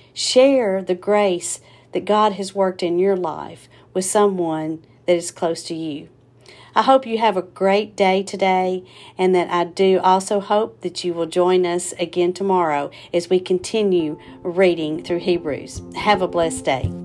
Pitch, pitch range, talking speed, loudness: 180 Hz, 165-195 Hz, 170 wpm, -19 LUFS